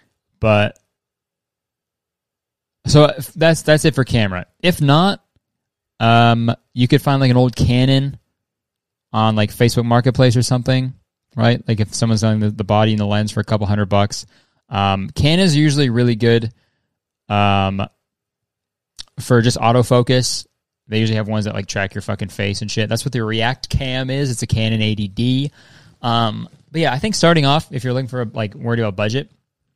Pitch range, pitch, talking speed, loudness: 110-130 Hz, 115 Hz, 175 wpm, -17 LUFS